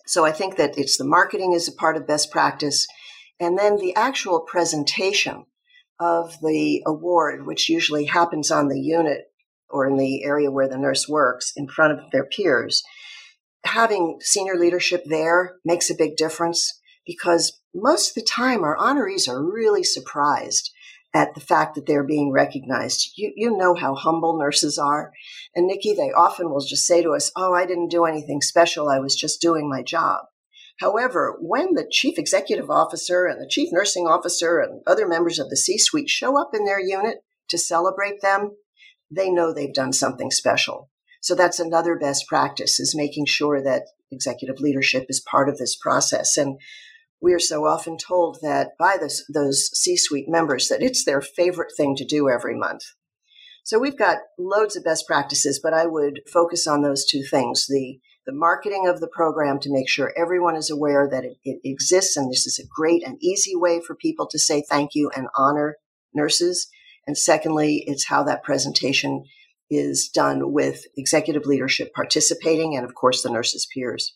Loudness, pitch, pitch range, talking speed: -21 LUFS, 165 Hz, 145-180 Hz, 185 wpm